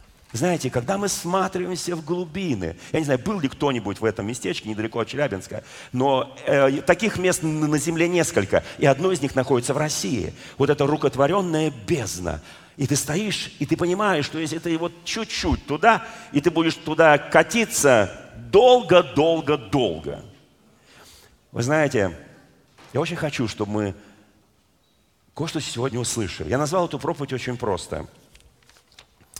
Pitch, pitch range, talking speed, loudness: 150 Hz, 125-175 Hz, 145 wpm, -22 LUFS